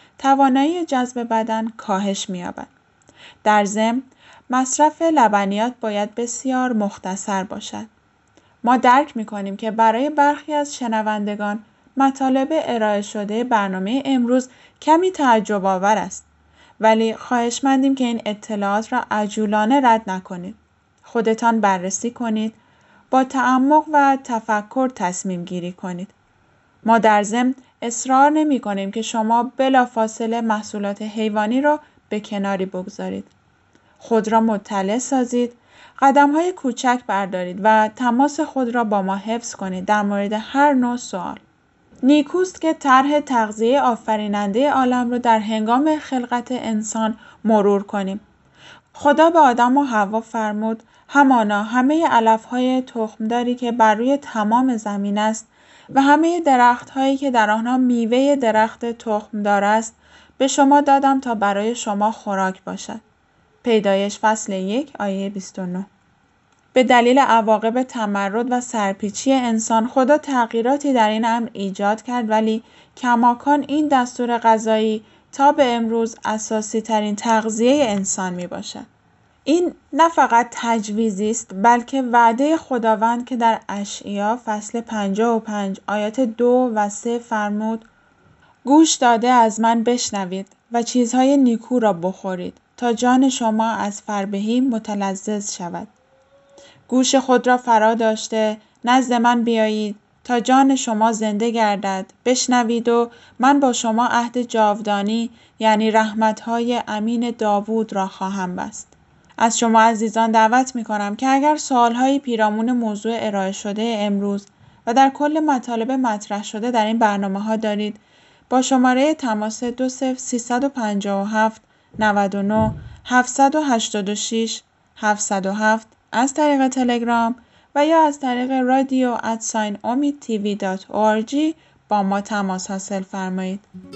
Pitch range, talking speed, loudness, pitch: 210-255 Hz, 125 wpm, -19 LUFS, 230 Hz